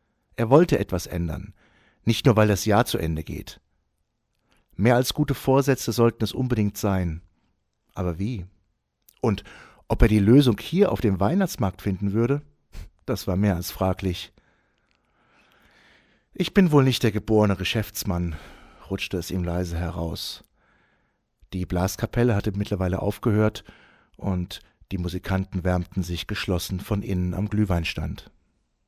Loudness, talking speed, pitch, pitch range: -24 LUFS, 135 wpm, 100 Hz, 90-115 Hz